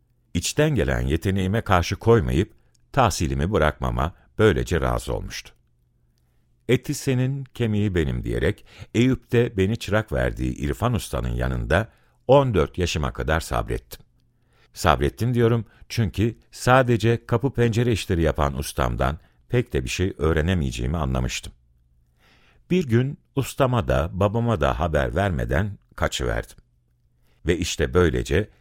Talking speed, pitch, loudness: 115 wpm, 85 Hz, -23 LUFS